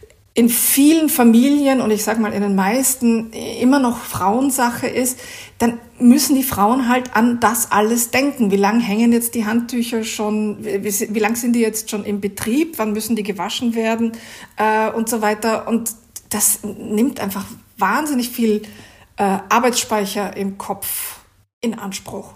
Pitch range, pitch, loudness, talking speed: 210-240 Hz, 225 Hz, -17 LUFS, 165 wpm